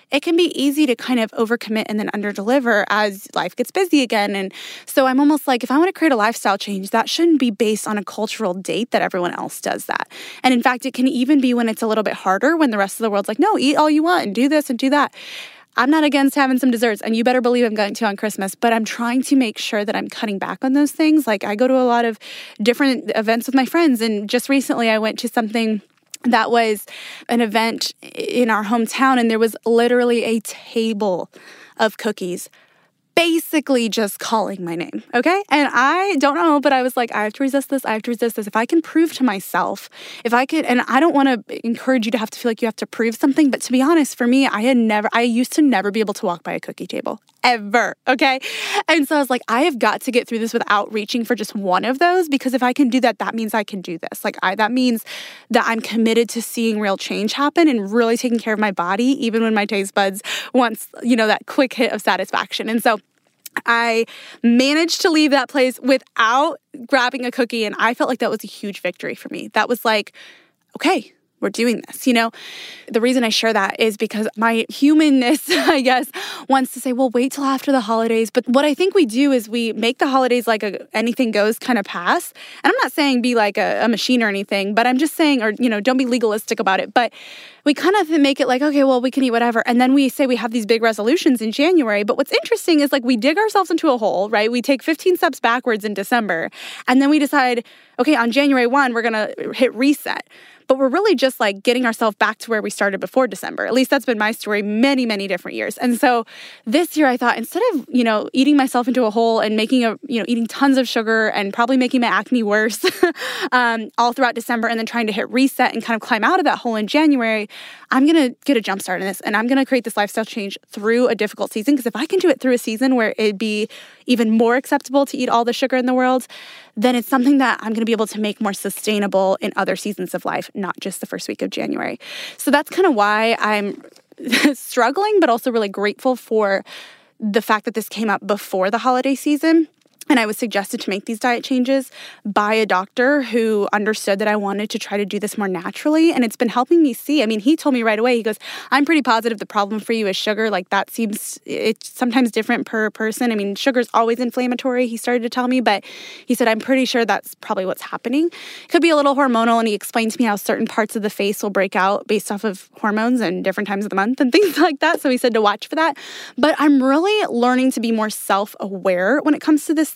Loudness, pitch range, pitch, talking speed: -18 LUFS, 220-275 Hz, 240 Hz, 250 wpm